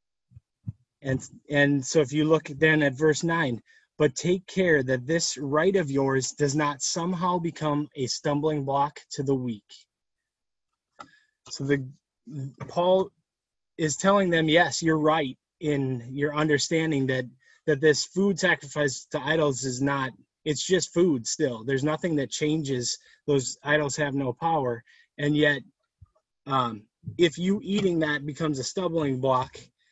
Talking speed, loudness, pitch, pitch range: 145 wpm, -26 LUFS, 150 Hz, 135-160 Hz